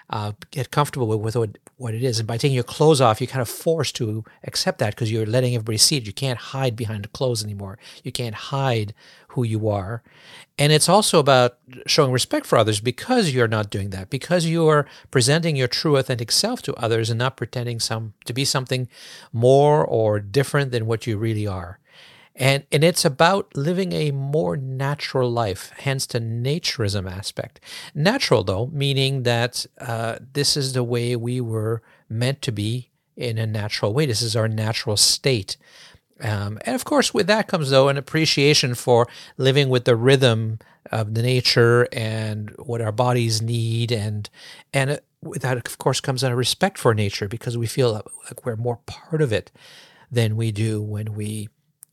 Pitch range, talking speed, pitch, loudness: 110-140 Hz, 190 wpm, 125 Hz, -21 LUFS